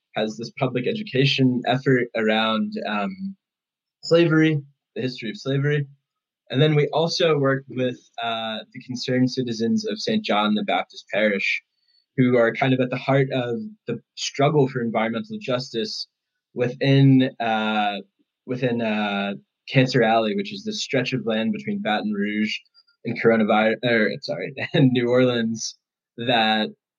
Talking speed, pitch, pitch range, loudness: 145 wpm, 125 Hz, 110-140 Hz, -22 LUFS